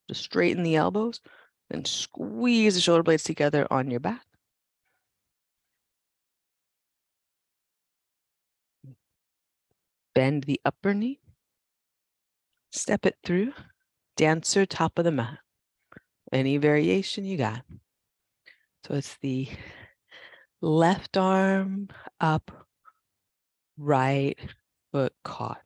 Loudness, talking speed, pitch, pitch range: -26 LUFS, 90 wpm, 160 Hz, 135-195 Hz